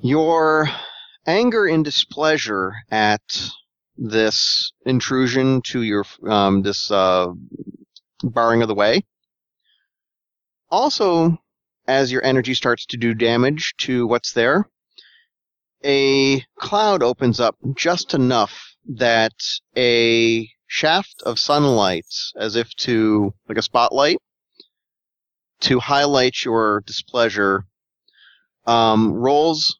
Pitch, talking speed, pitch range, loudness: 120 Hz, 100 wpm, 110-140 Hz, -18 LUFS